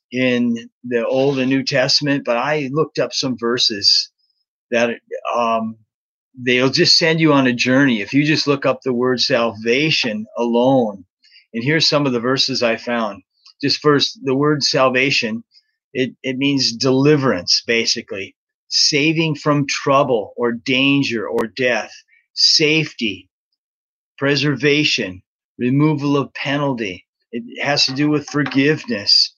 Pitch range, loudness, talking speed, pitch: 125-150 Hz, -16 LUFS, 135 wpm, 135 Hz